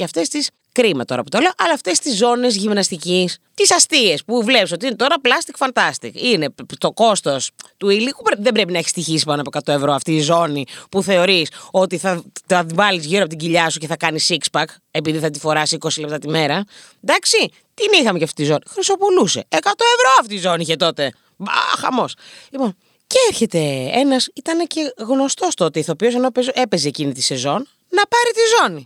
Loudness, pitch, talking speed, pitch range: -17 LUFS, 190 Hz, 200 wpm, 160-265 Hz